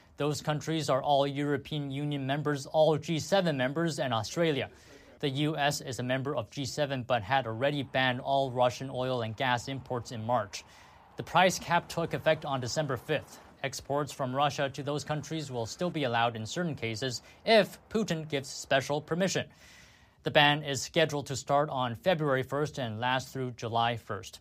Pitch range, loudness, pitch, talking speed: 125-150 Hz, -30 LUFS, 140 Hz, 175 wpm